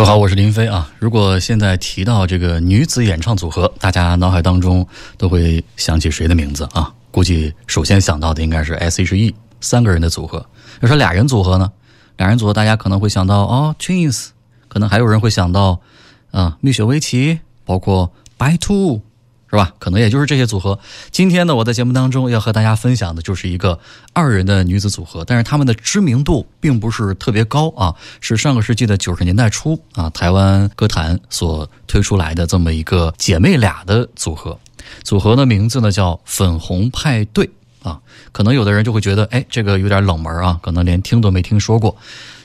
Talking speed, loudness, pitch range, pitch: 310 characters per minute, -15 LUFS, 90-120 Hz, 105 Hz